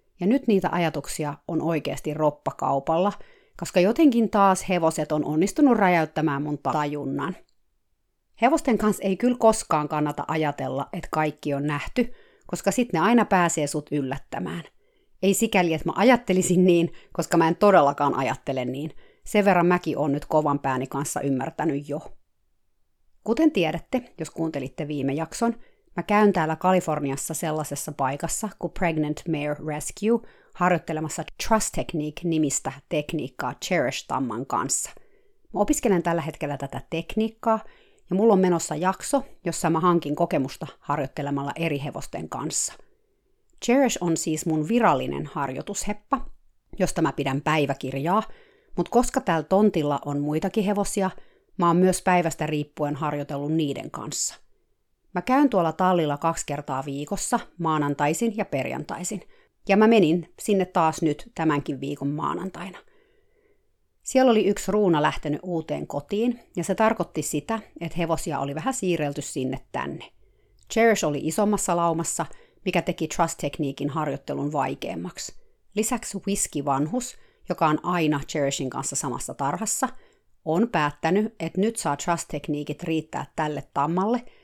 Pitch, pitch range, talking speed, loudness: 165 Hz, 150-205 Hz, 130 wpm, -25 LUFS